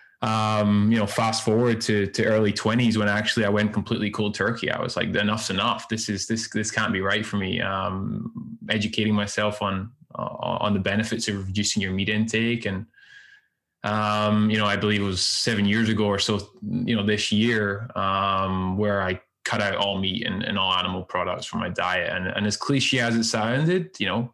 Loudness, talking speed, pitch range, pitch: -24 LUFS, 205 wpm, 100-115 Hz, 105 Hz